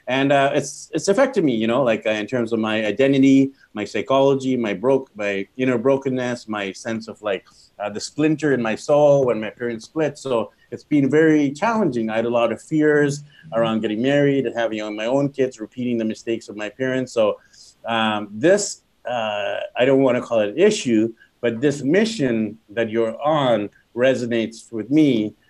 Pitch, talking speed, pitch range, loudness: 125 Hz, 200 wpm, 110-140 Hz, -20 LUFS